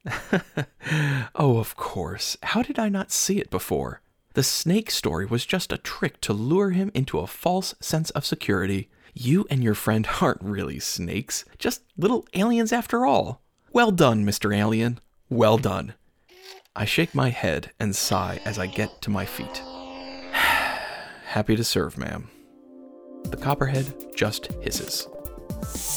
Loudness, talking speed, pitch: -25 LUFS, 150 wpm, 125 Hz